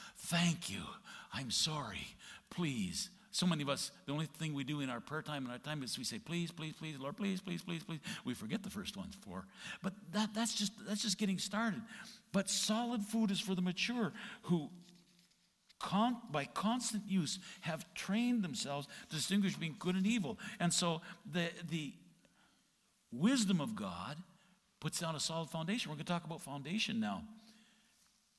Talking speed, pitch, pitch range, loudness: 180 wpm, 190 Hz, 165-215 Hz, -39 LUFS